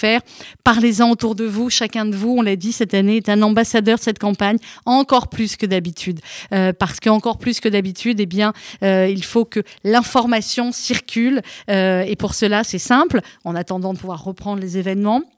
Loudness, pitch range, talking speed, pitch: -18 LUFS, 195-235 Hz, 195 wpm, 215 Hz